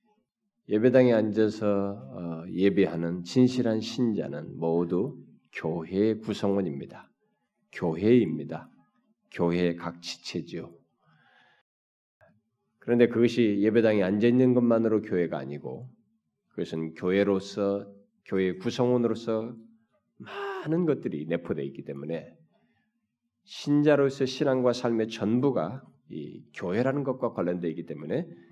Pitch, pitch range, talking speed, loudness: 110 Hz, 90-130 Hz, 255 characters per minute, -27 LUFS